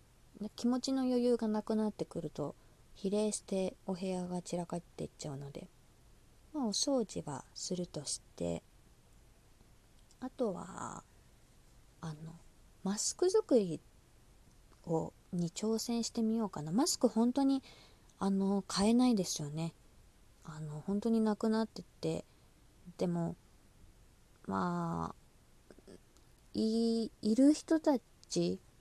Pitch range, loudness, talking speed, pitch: 140-225 Hz, -35 LUFS, 215 characters per minute, 185 Hz